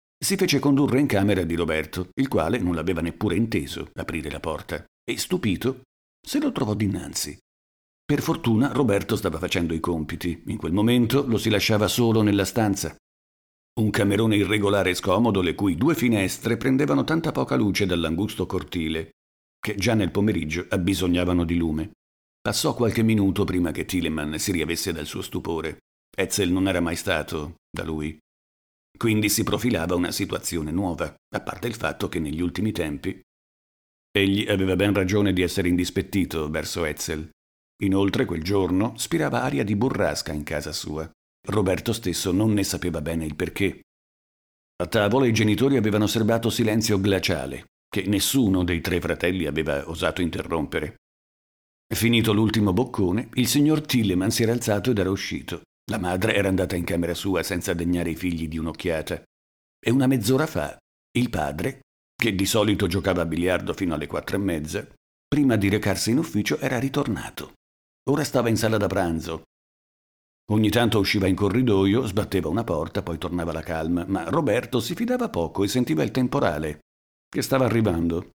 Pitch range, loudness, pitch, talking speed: 80-110 Hz, -24 LUFS, 95 Hz, 165 wpm